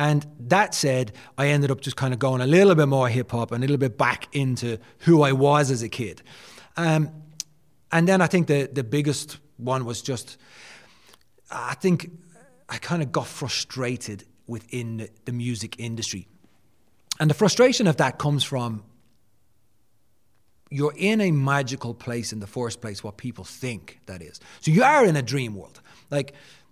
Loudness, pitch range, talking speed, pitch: -23 LUFS, 120-150 Hz, 180 wpm, 130 Hz